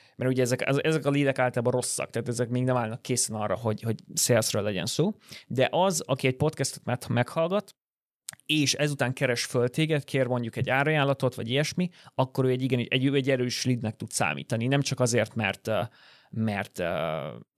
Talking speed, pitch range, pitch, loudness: 190 wpm, 120-140 Hz, 130 Hz, -27 LUFS